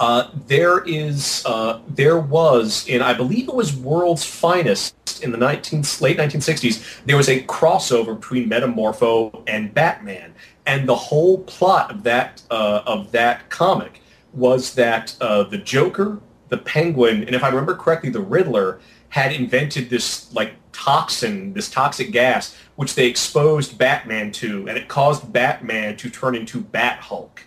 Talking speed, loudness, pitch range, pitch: 155 wpm, -19 LUFS, 120-155 Hz, 130 Hz